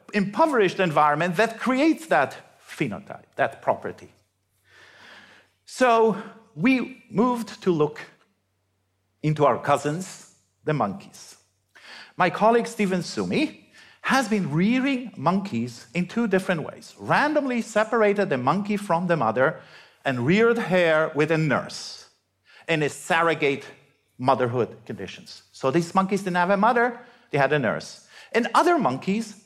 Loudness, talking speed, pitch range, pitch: -23 LUFS, 125 wpm, 150-225 Hz, 190 Hz